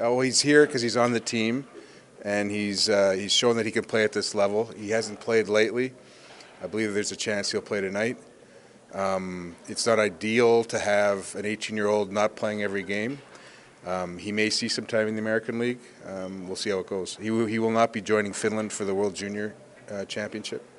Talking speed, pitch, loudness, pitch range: 220 wpm, 110 Hz, -26 LUFS, 100-115 Hz